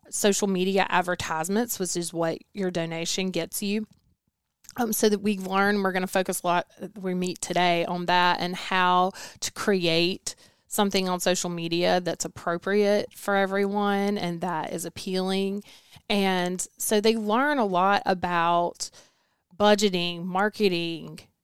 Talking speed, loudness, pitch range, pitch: 145 wpm, -25 LUFS, 175-205 Hz, 185 Hz